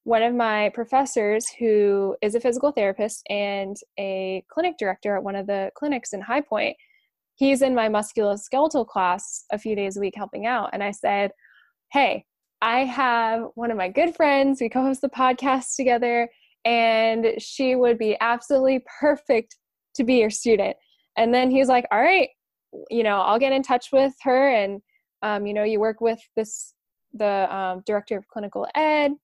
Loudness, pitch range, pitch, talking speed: -23 LUFS, 210-265 Hz, 230 Hz, 180 wpm